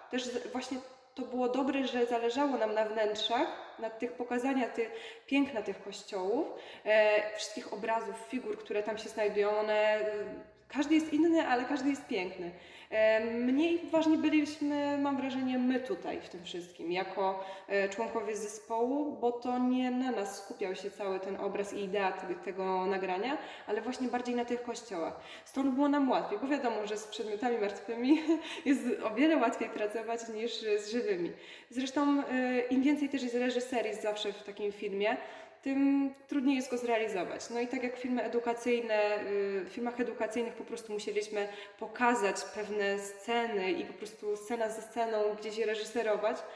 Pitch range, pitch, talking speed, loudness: 210-255 Hz, 230 Hz, 155 wpm, -33 LUFS